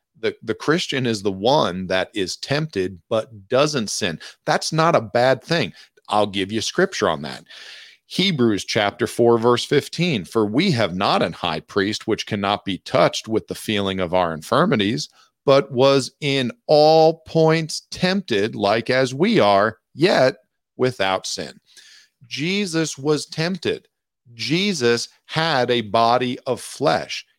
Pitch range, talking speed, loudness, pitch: 110-155 Hz, 145 wpm, -20 LUFS, 125 Hz